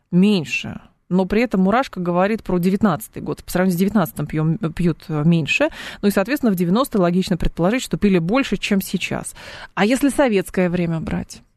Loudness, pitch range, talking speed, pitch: -19 LUFS, 170-210 Hz, 170 wpm, 185 Hz